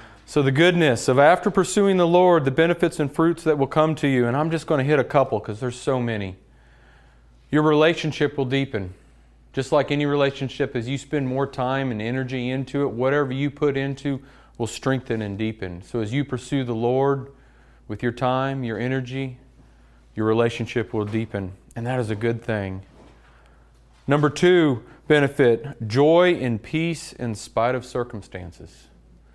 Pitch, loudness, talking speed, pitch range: 130 Hz, -22 LUFS, 175 wpm, 110-145 Hz